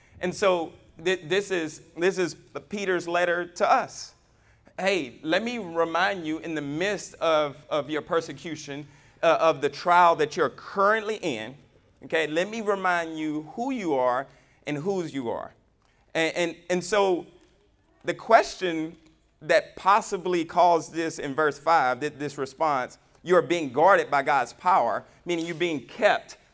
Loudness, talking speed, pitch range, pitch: -25 LUFS, 160 wpm, 150-180 Hz, 165 Hz